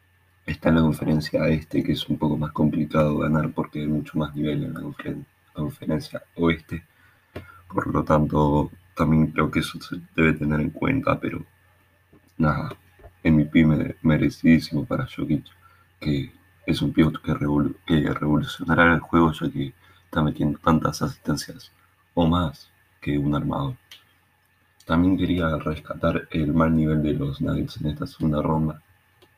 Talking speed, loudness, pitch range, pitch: 155 wpm, -23 LUFS, 75-90 Hz, 80 Hz